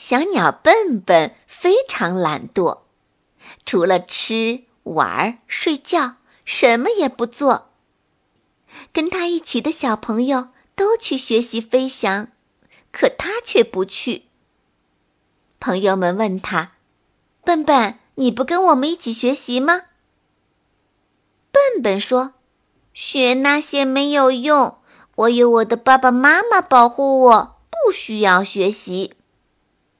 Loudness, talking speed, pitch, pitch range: -17 LUFS, 160 characters per minute, 255 Hz, 230-300 Hz